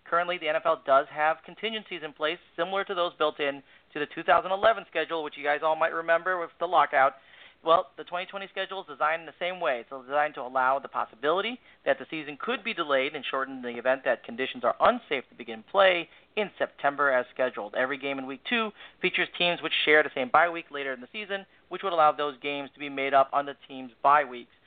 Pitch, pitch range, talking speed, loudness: 155 Hz, 140-175 Hz, 230 wpm, -27 LUFS